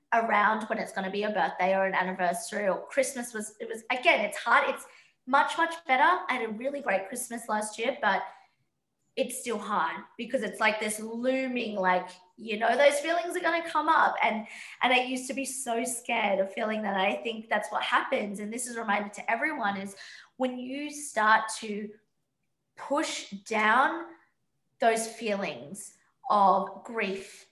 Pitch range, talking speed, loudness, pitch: 205-260 Hz, 185 wpm, -28 LUFS, 220 Hz